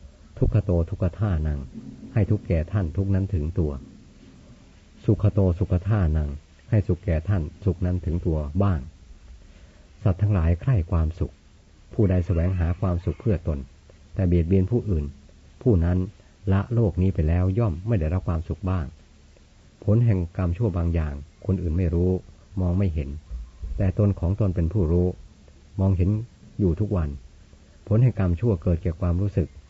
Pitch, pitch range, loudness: 90 Hz, 80-100 Hz, -25 LUFS